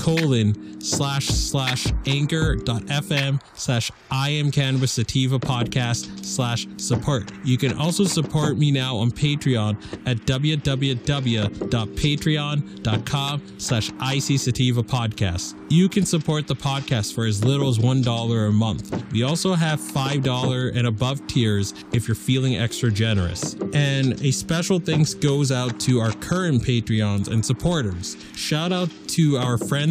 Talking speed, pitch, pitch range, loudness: 135 wpm, 130 Hz, 115-145 Hz, -22 LUFS